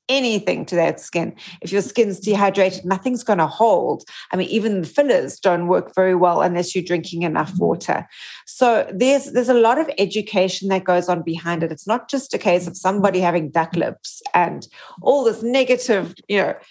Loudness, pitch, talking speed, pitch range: -19 LUFS, 195 Hz, 195 wpm, 175-230 Hz